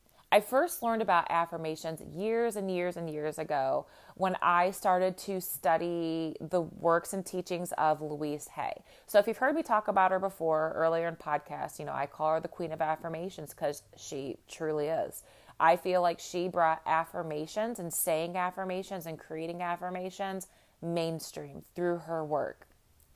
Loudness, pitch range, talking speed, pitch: -32 LUFS, 160-185 Hz, 165 wpm, 170 Hz